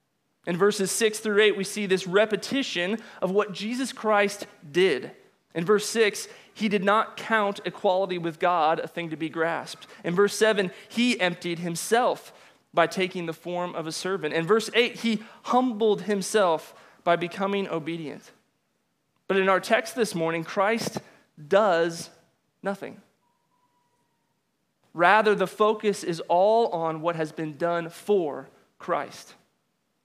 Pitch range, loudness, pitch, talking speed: 170-215 Hz, -25 LUFS, 195 Hz, 145 wpm